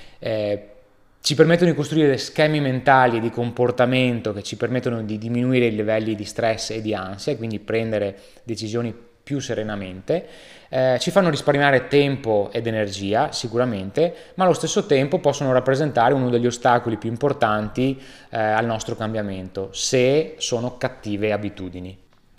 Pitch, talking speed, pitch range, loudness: 120 Hz, 145 wpm, 110-135 Hz, -21 LUFS